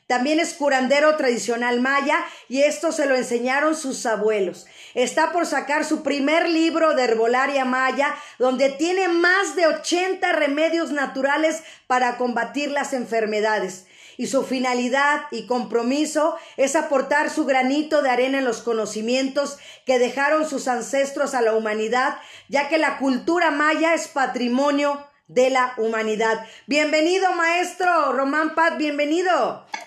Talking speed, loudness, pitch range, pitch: 135 wpm, -21 LUFS, 250-310 Hz, 280 Hz